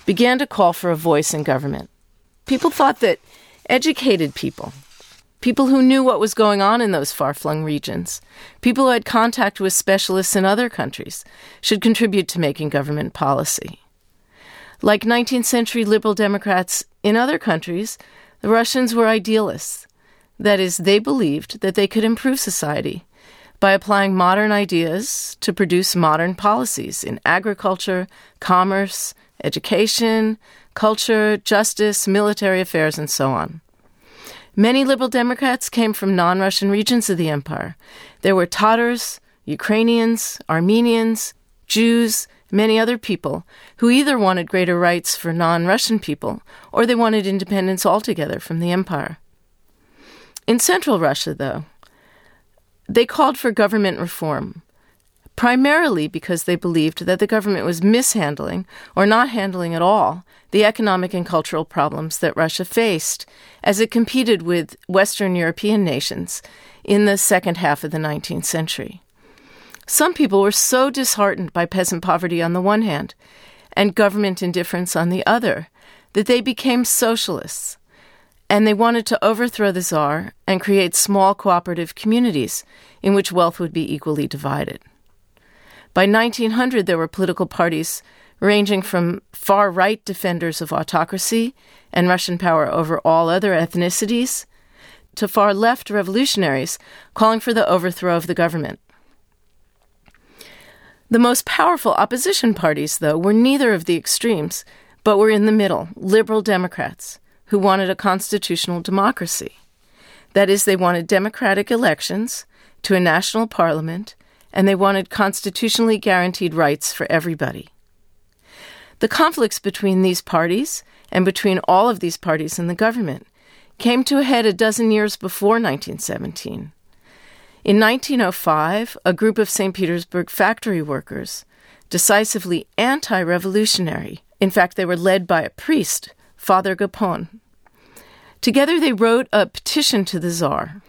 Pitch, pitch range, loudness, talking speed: 200 Hz, 175-225 Hz, -18 LUFS, 140 wpm